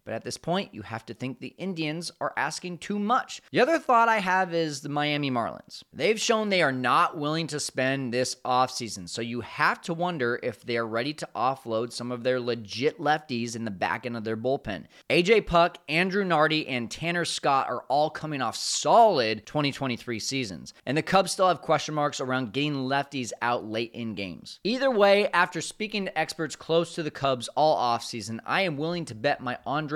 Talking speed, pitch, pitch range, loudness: 205 wpm, 145 Hz, 120-170 Hz, -26 LUFS